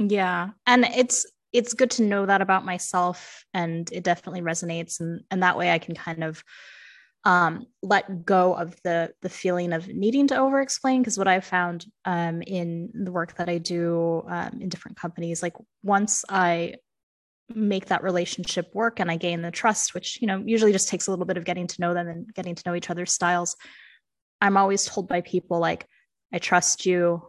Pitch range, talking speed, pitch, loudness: 175-200 Hz, 200 wpm, 180 Hz, -24 LUFS